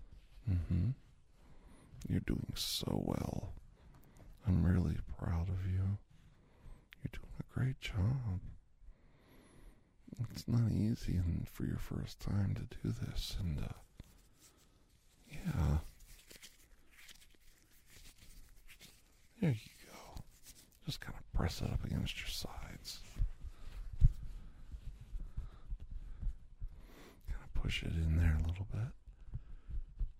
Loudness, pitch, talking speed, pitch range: -39 LUFS, 95 Hz, 95 wpm, 85-115 Hz